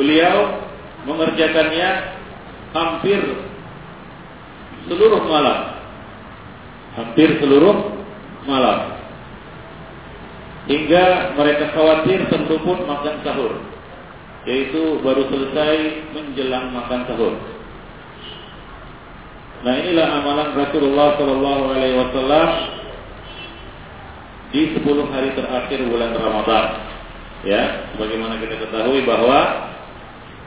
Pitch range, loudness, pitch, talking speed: 125-160 Hz, -18 LUFS, 145 Hz, 75 wpm